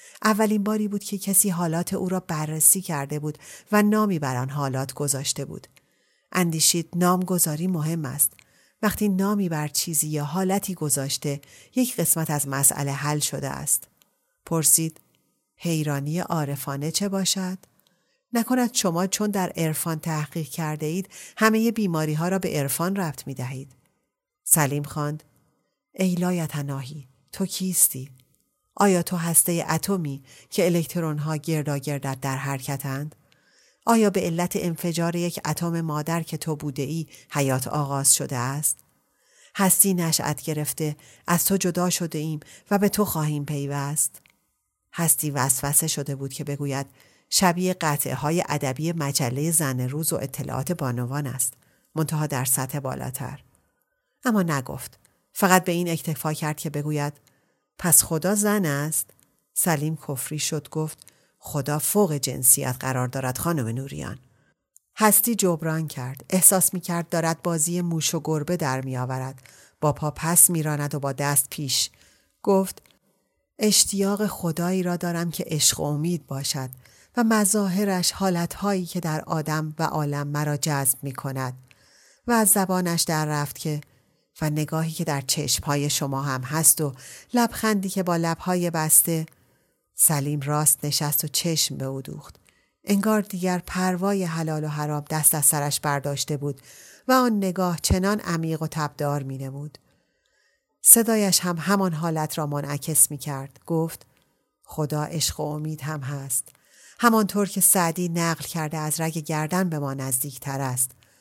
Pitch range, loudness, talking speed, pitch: 145-180 Hz, -23 LUFS, 145 wpm, 155 Hz